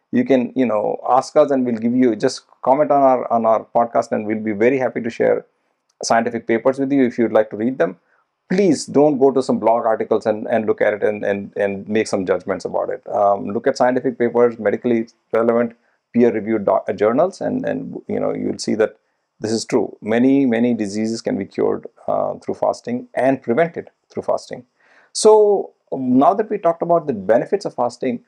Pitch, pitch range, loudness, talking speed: 120 Hz, 115-140 Hz, -18 LUFS, 210 wpm